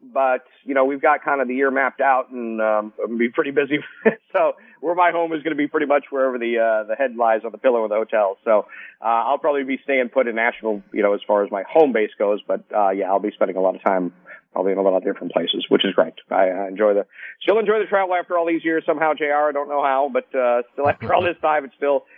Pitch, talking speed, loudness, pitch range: 135 Hz, 280 wpm, -20 LUFS, 110-150 Hz